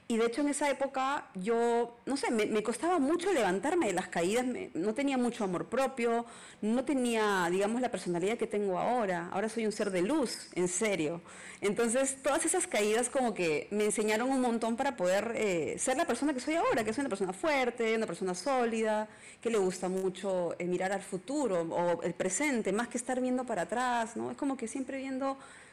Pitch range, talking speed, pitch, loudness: 195-265 Hz, 210 wpm, 230 Hz, -32 LUFS